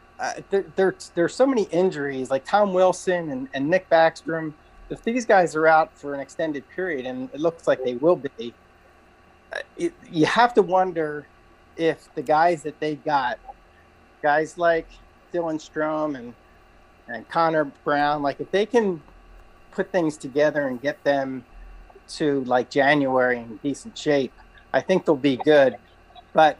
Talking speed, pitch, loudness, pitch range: 165 wpm, 155 Hz, -23 LUFS, 140-180 Hz